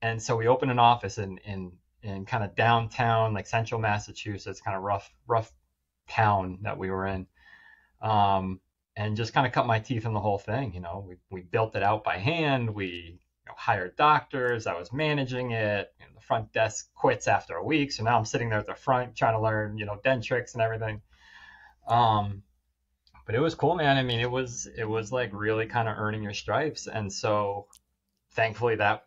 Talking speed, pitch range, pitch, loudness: 210 wpm, 100-120 Hz, 110 Hz, -28 LUFS